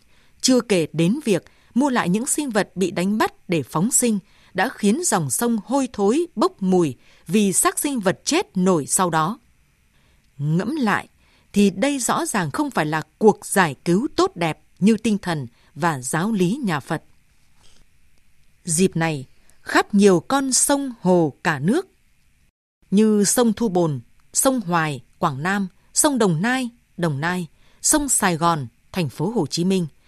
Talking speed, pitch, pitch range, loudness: 165 wpm, 190 Hz, 170-235 Hz, -20 LUFS